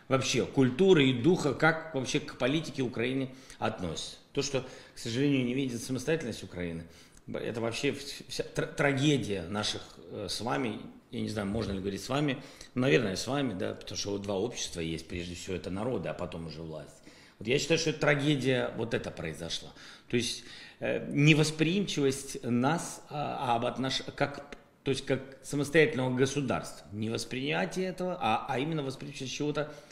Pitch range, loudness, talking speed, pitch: 105-145 Hz, -31 LUFS, 160 wpm, 130 Hz